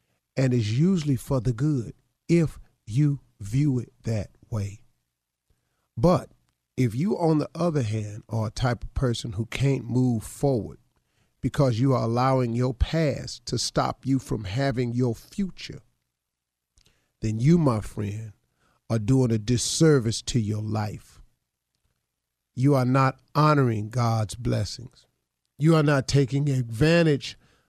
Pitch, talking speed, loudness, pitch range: 125 Hz, 135 wpm, -25 LUFS, 110-140 Hz